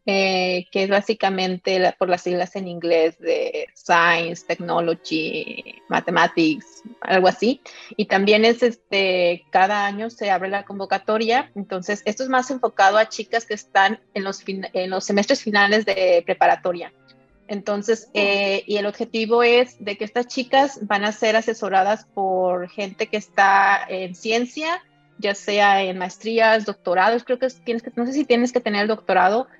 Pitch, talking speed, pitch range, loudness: 205 Hz, 165 wpm, 190-230 Hz, -20 LUFS